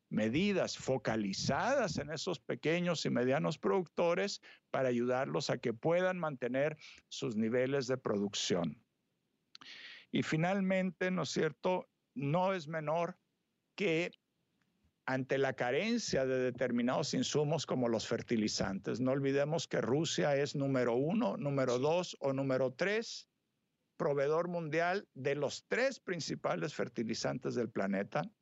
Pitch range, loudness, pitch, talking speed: 130-175 Hz, -35 LUFS, 145 Hz, 120 wpm